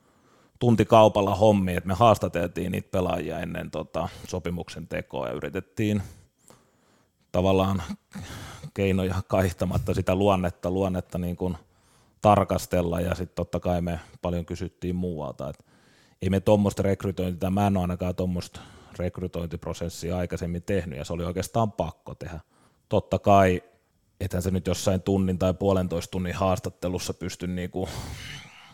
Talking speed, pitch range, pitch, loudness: 130 wpm, 90-100 Hz, 95 Hz, -26 LUFS